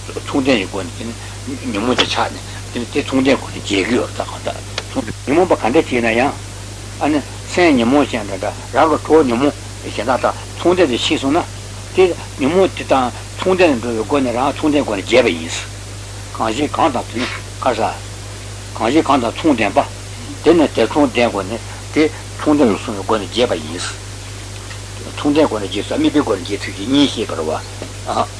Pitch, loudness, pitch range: 105 Hz, -17 LUFS, 100-120 Hz